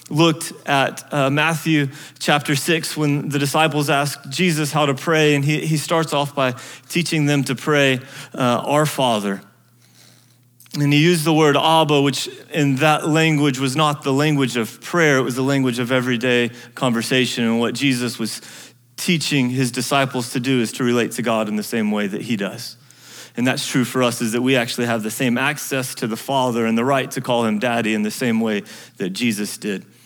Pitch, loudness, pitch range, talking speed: 135 Hz, -19 LUFS, 120-150 Hz, 200 wpm